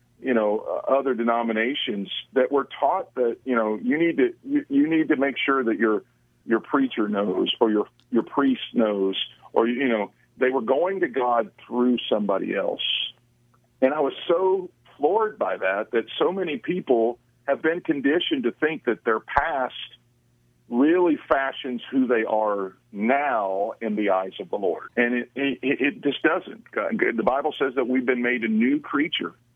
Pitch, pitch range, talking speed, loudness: 130 Hz, 115-170 Hz, 180 wpm, -24 LUFS